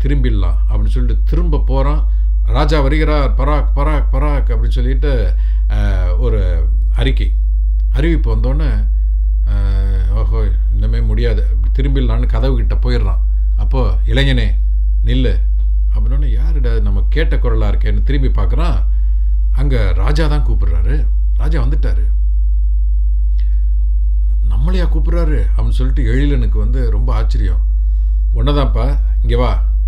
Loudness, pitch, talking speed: -16 LUFS, 95 Hz, 100 wpm